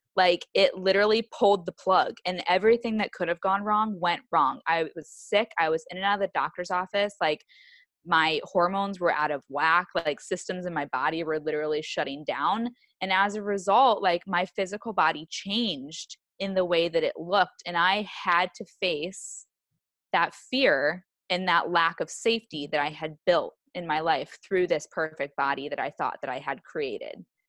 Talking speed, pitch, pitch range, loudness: 190 wpm, 180 Hz, 160-205 Hz, -26 LUFS